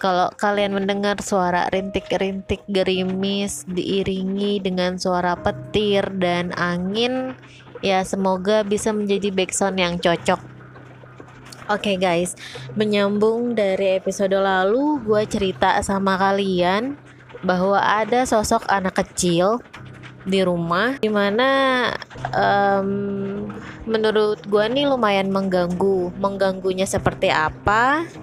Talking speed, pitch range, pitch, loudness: 100 wpm, 185-210 Hz, 195 Hz, -20 LUFS